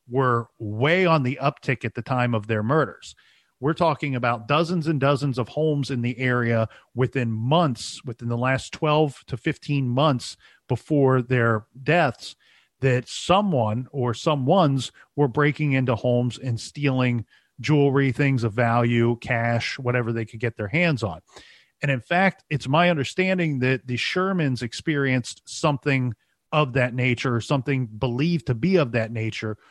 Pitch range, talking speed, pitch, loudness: 120-150 Hz, 160 wpm, 130 Hz, -23 LUFS